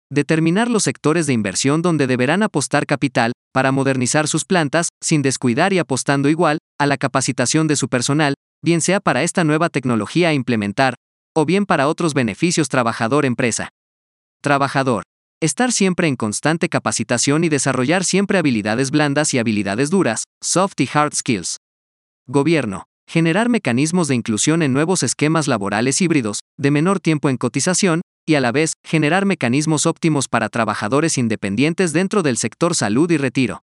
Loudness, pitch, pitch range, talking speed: -18 LUFS, 145 Hz, 125-165 Hz, 155 wpm